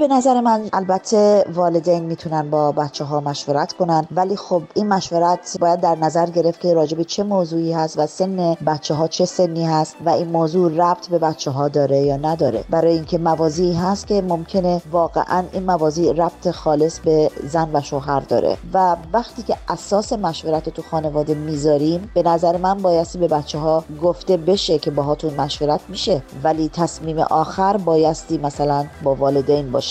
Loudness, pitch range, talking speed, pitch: -19 LUFS, 155-180 Hz, 175 wpm, 165 Hz